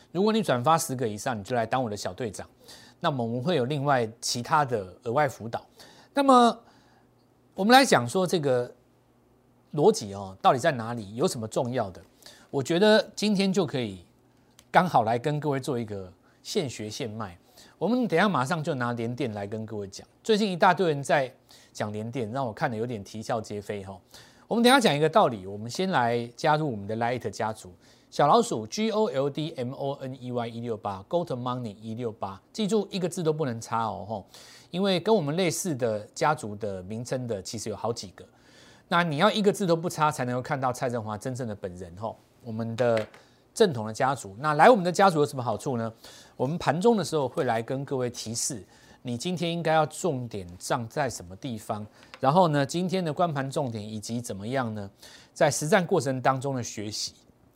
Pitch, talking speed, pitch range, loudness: 130 Hz, 310 characters per minute, 115-165 Hz, -27 LUFS